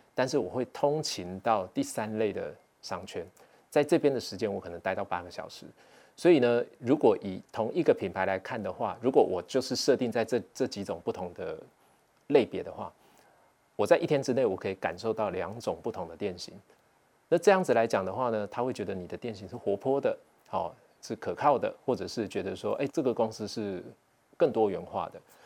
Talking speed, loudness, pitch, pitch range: 295 characters per minute, -30 LUFS, 120 Hz, 100-130 Hz